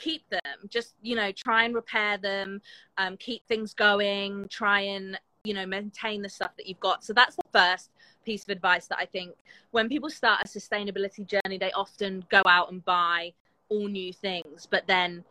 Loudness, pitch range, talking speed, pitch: -27 LUFS, 190-215 Hz, 205 wpm, 200 Hz